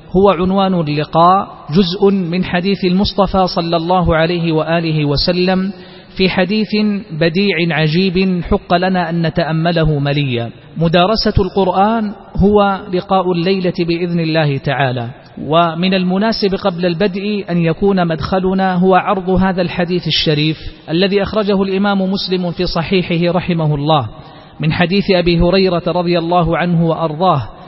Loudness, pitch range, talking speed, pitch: -14 LUFS, 165-190 Hz, 125 wpm, 180 Hz